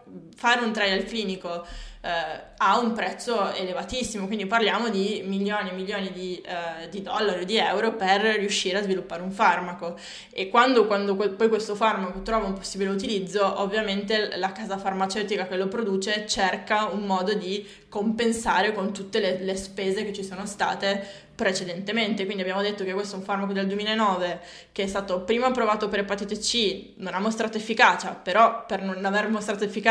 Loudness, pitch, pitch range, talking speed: -25 LUFS, 200 Hz, 190-215 Hz, 180 wpm